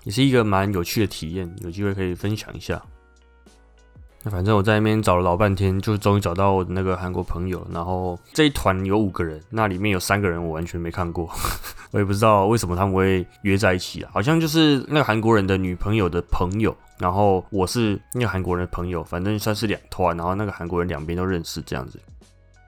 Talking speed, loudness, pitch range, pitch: 345 characters per minute, -22 LUFS, 90-105 Hz, 95 Hz